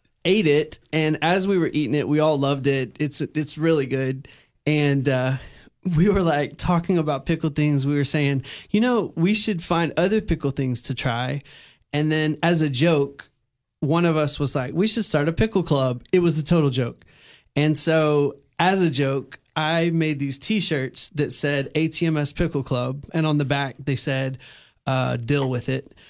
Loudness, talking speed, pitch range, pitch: -22 LUFS, 190 wpm, 140-165 Hz, 150 Hz